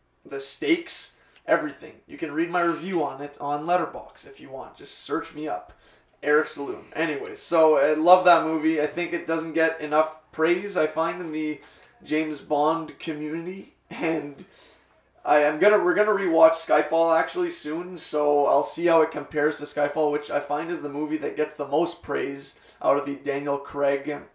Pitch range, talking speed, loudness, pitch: 150-170 Hz, 185 wpm, -24 LUFS, 155 Hz